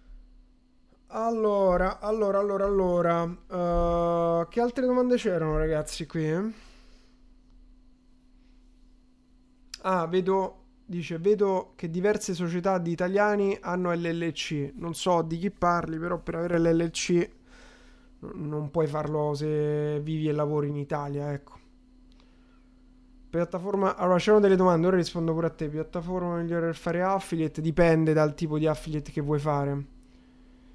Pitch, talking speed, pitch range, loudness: 175 Hz, 130 wpm, 160-220 Hz, -27 LUFS